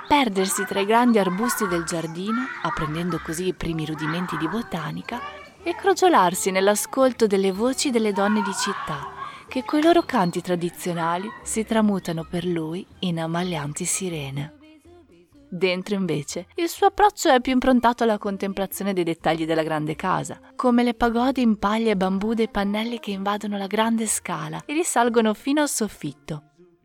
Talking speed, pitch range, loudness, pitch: 155 wpm, 175-240 Hz, -23 LUFS, 200 Hz